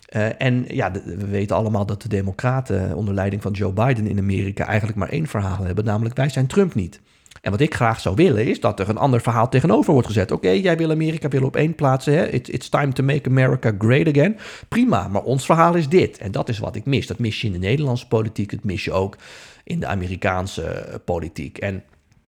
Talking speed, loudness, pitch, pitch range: 230 wpm, -20 LUFS, 115 Hz, 100-135 Hz